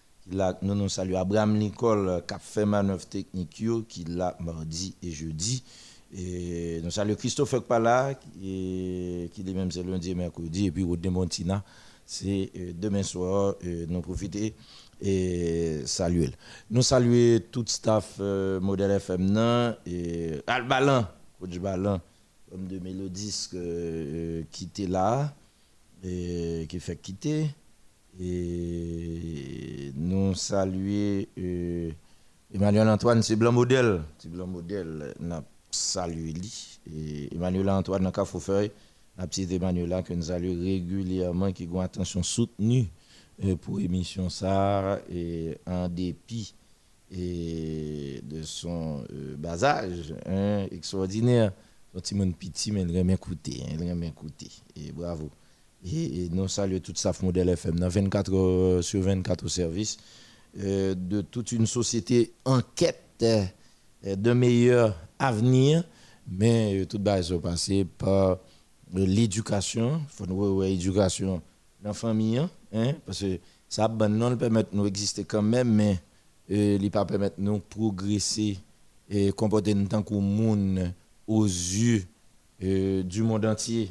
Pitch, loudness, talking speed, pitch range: 95 Hz, -28 LUFS, 135 wpm, 90-105 Hz